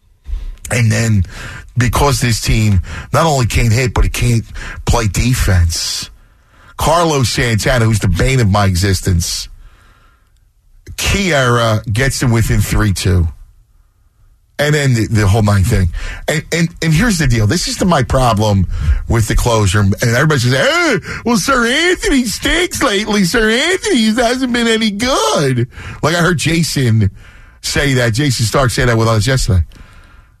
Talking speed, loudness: 150 wpm, -13 LUFS